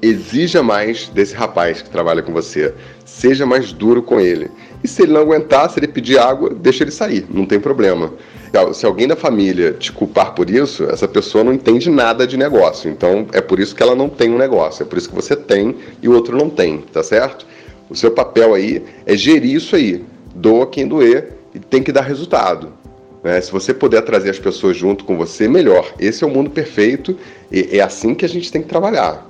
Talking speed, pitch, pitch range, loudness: 220 wpm, 135 Hz, 115-175 Hz, -14 LUFS